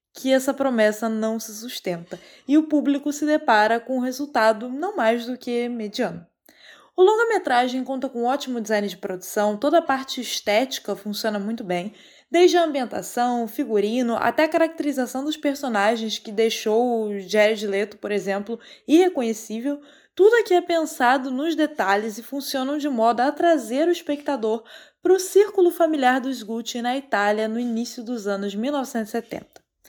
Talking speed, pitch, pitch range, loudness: 160 wpm, 245 Hz, 220-290 Hz, -22 LUFS